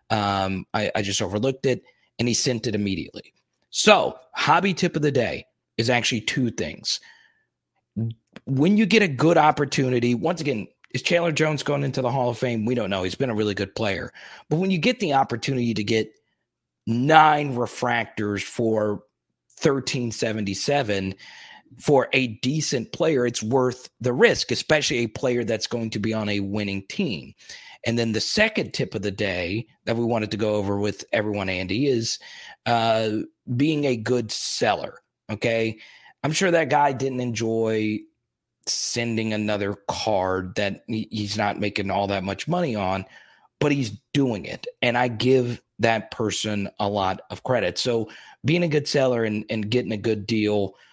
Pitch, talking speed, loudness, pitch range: 115 Hz, 170 wpm, -23 LUFS, 105-135 Hz